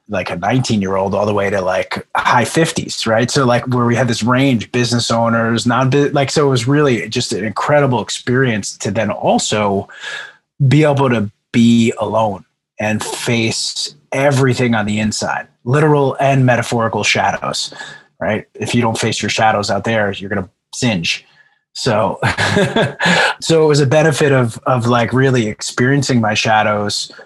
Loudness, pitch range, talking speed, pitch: -15 LUFS, 110-135 Hz, 155 wpm, 120 Hz